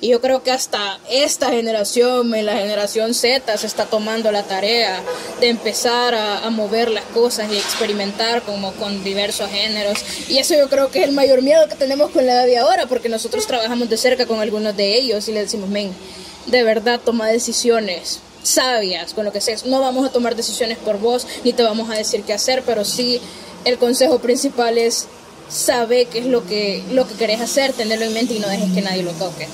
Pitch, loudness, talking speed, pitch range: 230 Hz, -17 LUFS, 210 wpm, 210-245 Hz